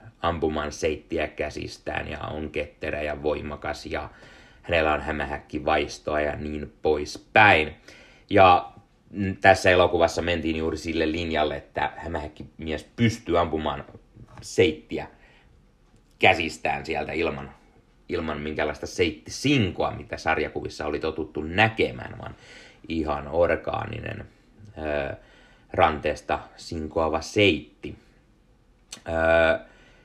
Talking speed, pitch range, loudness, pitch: 95 wpm, 75-85 Hz, -25 LUFS, 80 Hz